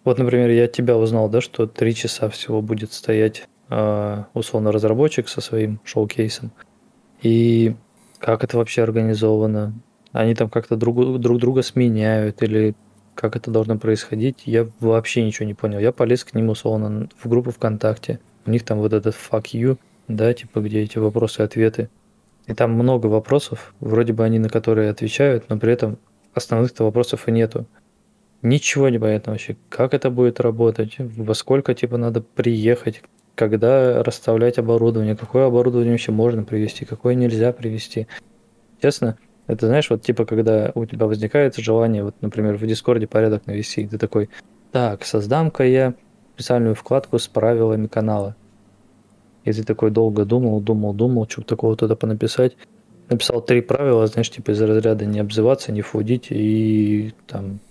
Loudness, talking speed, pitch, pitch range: -19 LUFS, 160 wpm, 115 Hz, 110-120 Hz